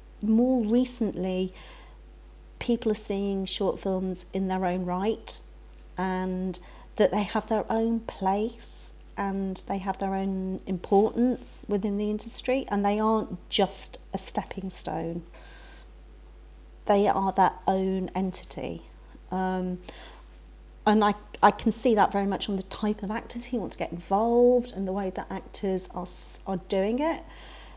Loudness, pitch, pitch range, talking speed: -28 LUFS, 195 Hz, 185-220 Hz, 145 wpm